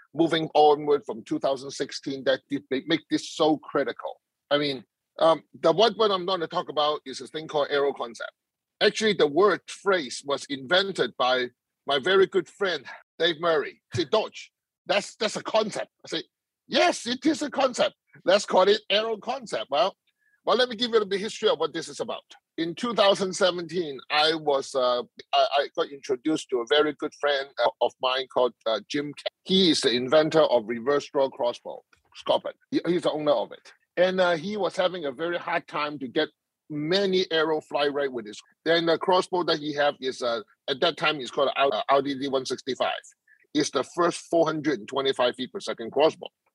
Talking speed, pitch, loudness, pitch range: 195 wpm, 165 Hz, -25 LUFS, 140-215 Hz